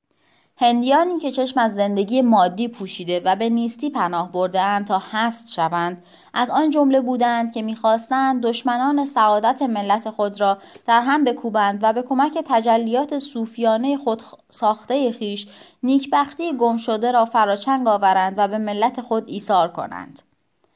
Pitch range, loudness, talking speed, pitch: 205-260 Hz, -20 LUFS, 140 wpm, 230 Hz